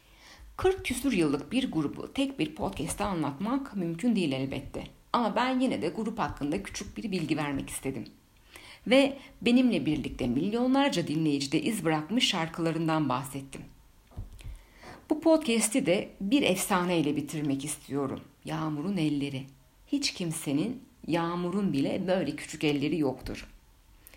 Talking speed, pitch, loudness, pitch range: 120 wpm, 165 Hz, -29 LUFS, 145-245 Hz